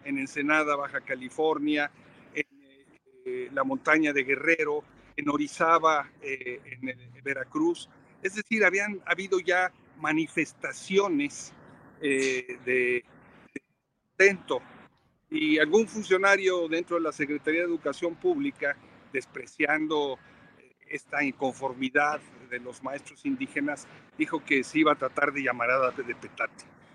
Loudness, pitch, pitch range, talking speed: -28 LUFS, 150 Hz, 135-190 Hz, 120 wpm